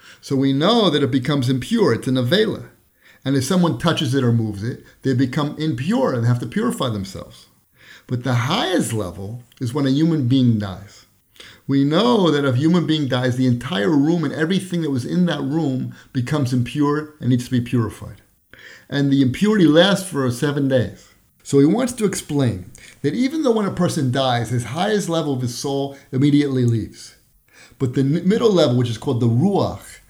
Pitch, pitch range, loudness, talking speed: 135 Hz, 125-160 Hz, -19 LUFS, 195 wpm